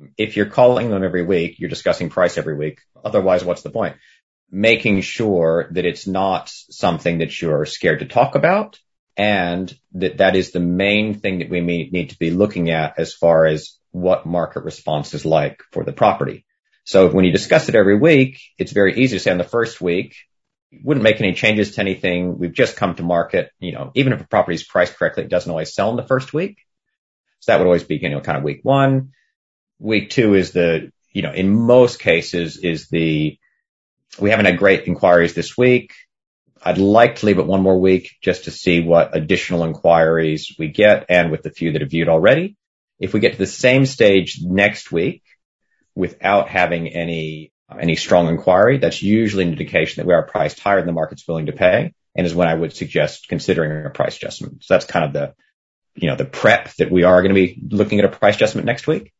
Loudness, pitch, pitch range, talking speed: -17 LUFS, 95 Hz, 85-105 Hz, 215 wpm